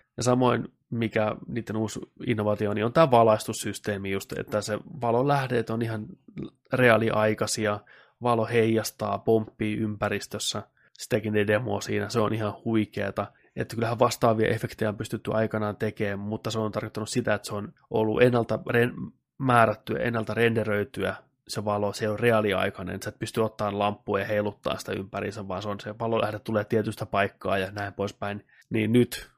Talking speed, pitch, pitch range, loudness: 160 wpm, 110 Hz, 105-115 Hz, -27 LUFS